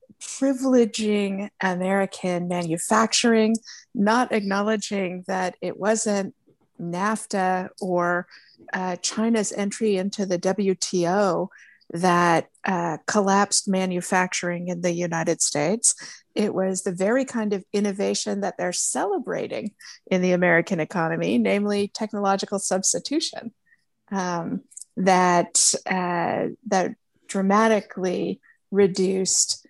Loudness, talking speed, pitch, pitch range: -23 LUFS, 95 wpm, 195 Hz, 180-215 Hz